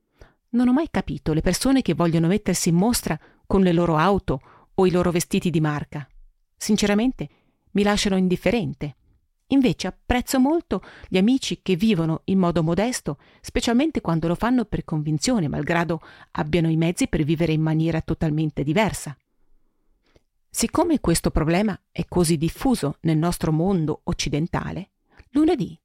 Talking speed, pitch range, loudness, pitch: 145 wpm, 160-210 Hz, -22 LUFS, 175 Hz